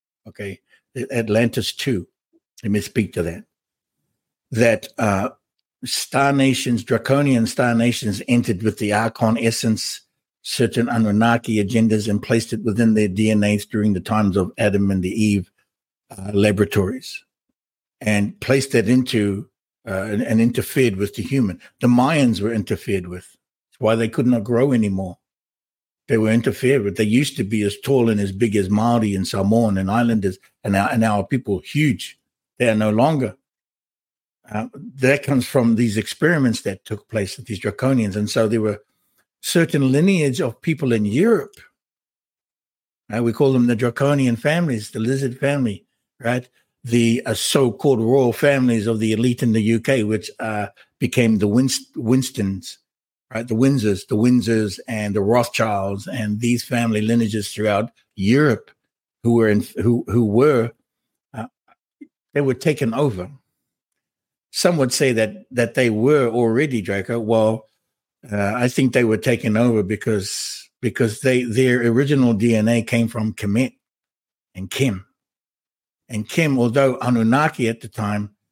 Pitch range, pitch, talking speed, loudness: 105-125 Hz, 115 Hz, 150 wpm, -19 LUFS